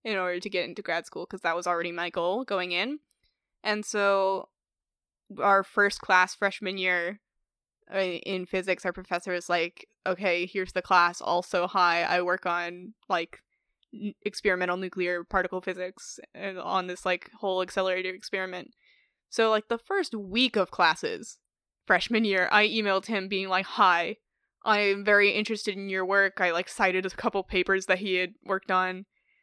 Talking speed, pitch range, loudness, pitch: 165 wpm, 180-205 Hz, -27 LUFS, 190 Hz